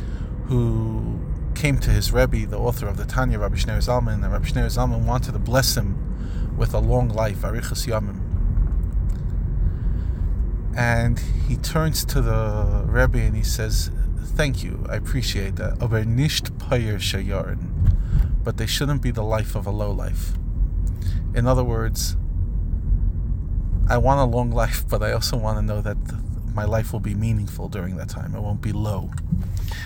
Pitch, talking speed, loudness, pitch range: 105 Hz, 160 wpm, -23 LUFS, 90-115 Hz